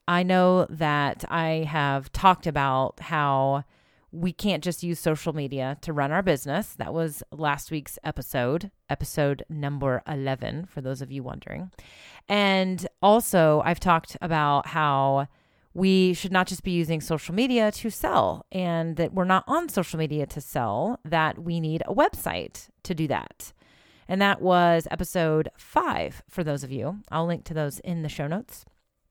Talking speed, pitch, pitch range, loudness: 165 wpm, 165 Hz, 145-180 Hz, -25 LUFS